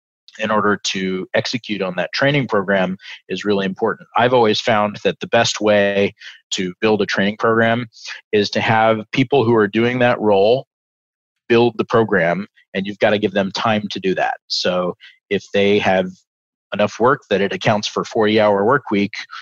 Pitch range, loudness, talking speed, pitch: 95-110 Hz, -17 LUFS, 180 wpm, 105 Hz